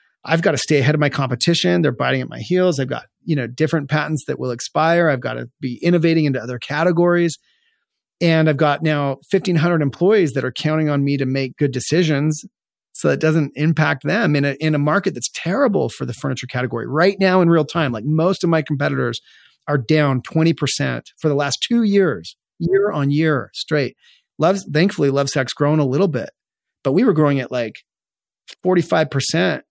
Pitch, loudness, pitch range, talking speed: 155 Hz, -18 LUFS, 140-170 Hz, 210 wpm